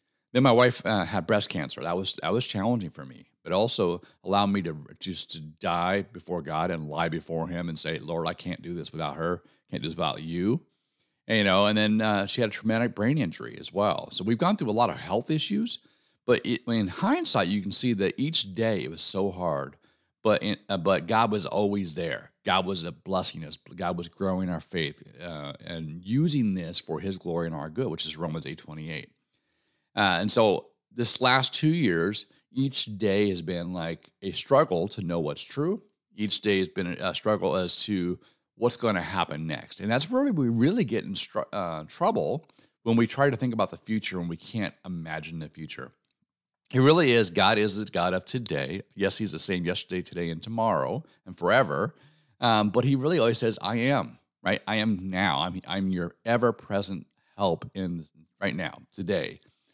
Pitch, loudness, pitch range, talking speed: 100 Hz, -27 LUFS, 85-115 Hz, 210 wpm